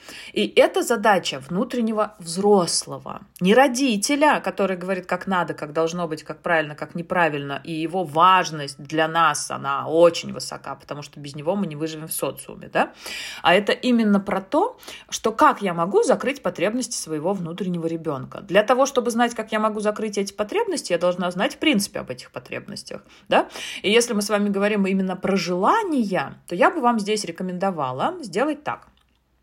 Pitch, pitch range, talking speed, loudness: 185 Hz, 165-220 Hz, 175 wpm, -22 LUFS